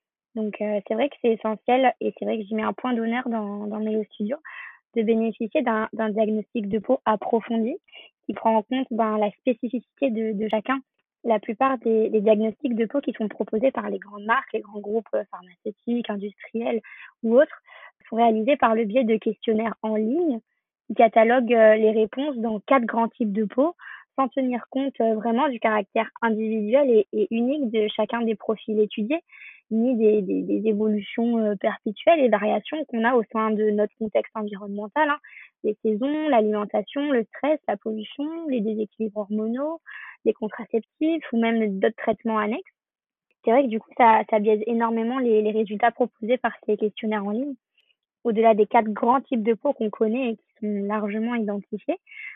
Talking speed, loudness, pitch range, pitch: 180 wpm, -24 LUFS, 215-255 Hz, 225 Hz